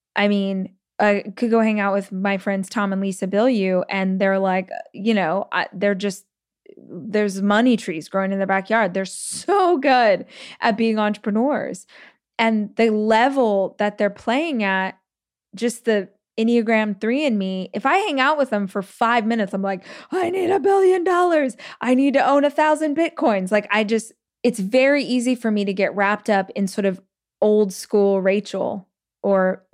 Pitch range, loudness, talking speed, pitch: 195-250 Hz, -20 LUFS, 185 wpm, 210 Hz